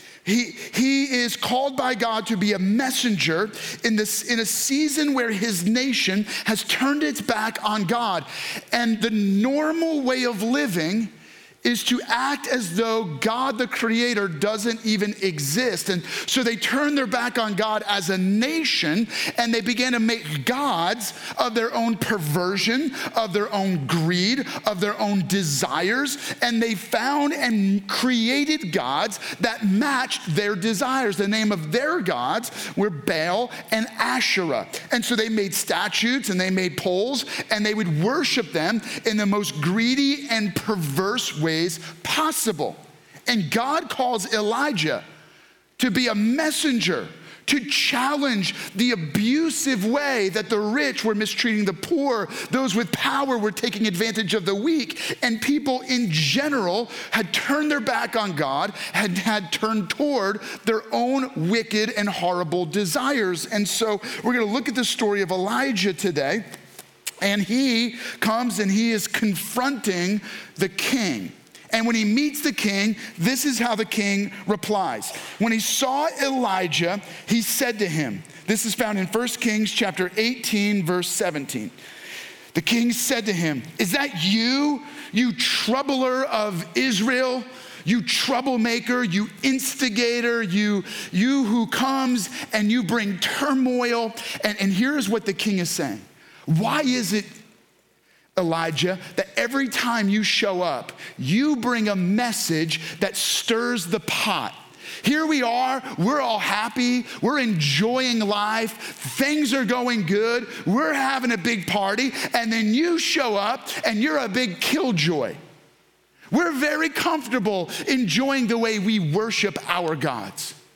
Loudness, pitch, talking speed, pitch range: -22 LUFS, 225 Hz, 150 wpm, 205-255 Hz